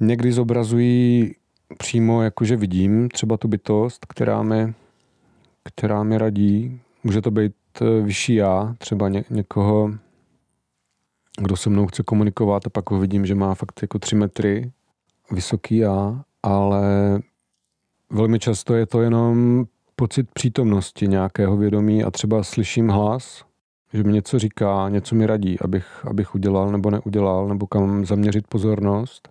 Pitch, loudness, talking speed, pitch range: 105 Hz, -20 LUFS, 140 wpm, 100-115 Hz